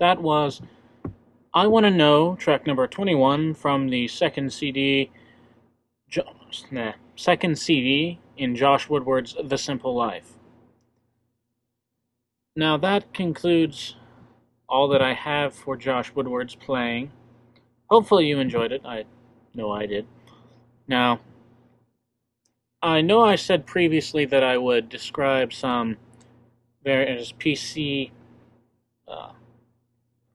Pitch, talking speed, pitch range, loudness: 130 Hz, 110 wpm, 120-145 Hz, -22 LUFS